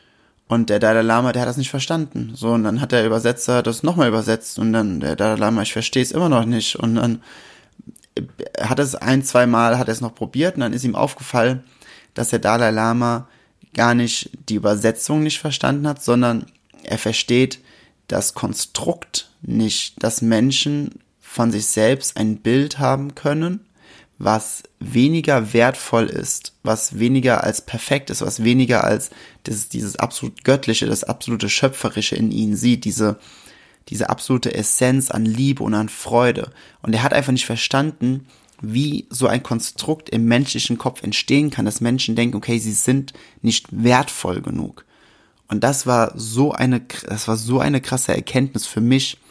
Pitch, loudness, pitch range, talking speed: 120 Hz, -19 LUFS, 110-130 Hz, 170 wpm